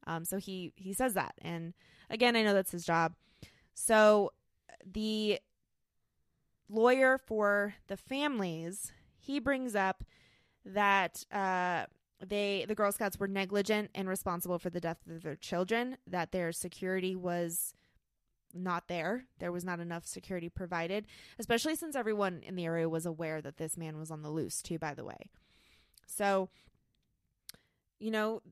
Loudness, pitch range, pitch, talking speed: -34 LUFS, 170-210 Hz, 190 Hz, 150 wpm